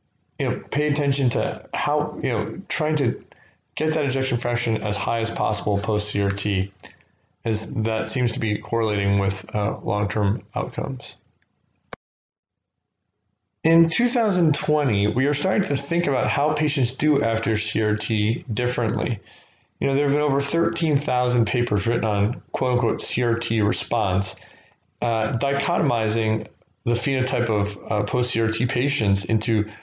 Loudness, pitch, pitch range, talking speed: -23 LUFS, 115 Hz, 105-140 Hz, 130 wpm